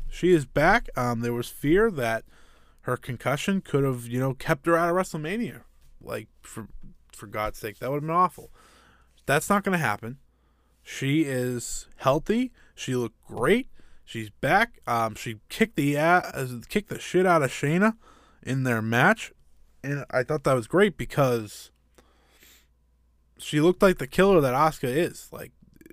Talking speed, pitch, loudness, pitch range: 165 wpm, 135 Hz, -25 LUFS, 115-170 Hz